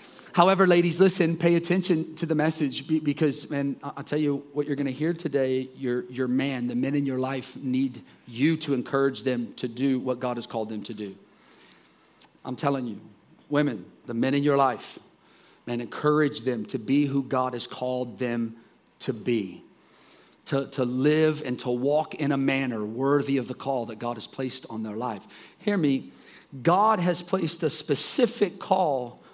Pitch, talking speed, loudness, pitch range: 135 Hz, 180 wpm, -26 LUFS, 125-150 Hz